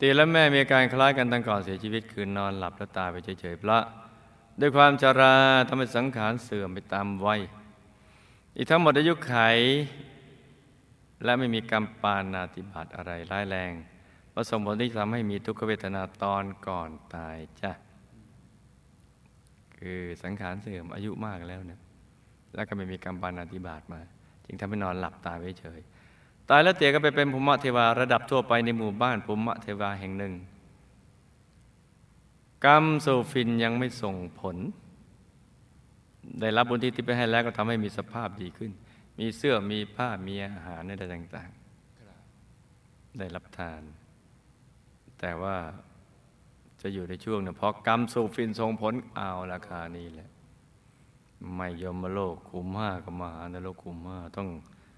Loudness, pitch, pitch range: -27 LUFS, 105 Hz, 90-120 Hz